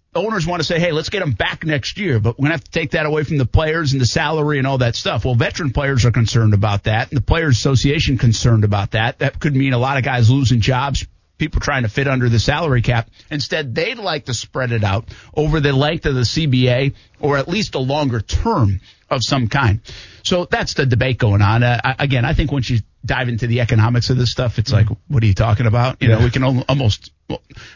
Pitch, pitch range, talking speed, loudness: 125 Hz, 115-145 Hz, 250 wpm, -17 LUFS